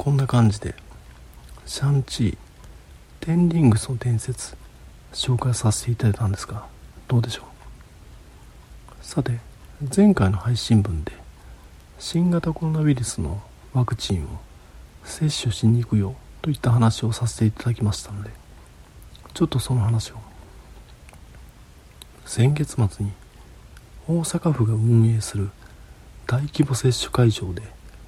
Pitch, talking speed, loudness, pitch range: 115 Hz, 250 characters per minute, -22 LUFS, 90-130 Hz